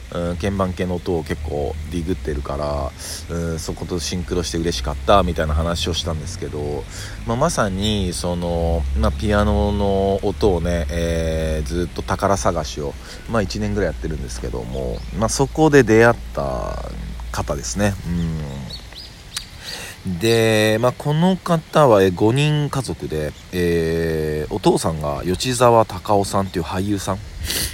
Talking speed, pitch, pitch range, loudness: 290 characters per minute, 90 Hz, 80-105 Hz, -20 LUFS